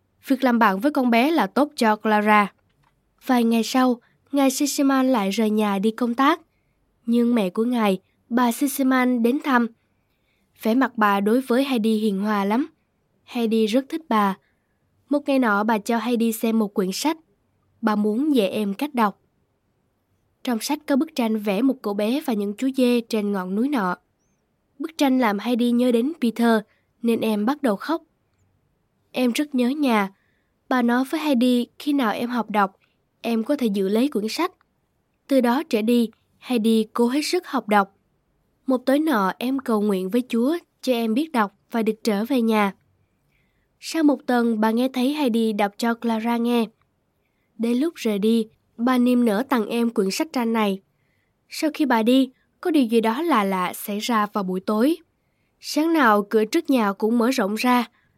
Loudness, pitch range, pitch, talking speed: -22 LUFS, 215-265 Hz, 235 Hz, 190 wpm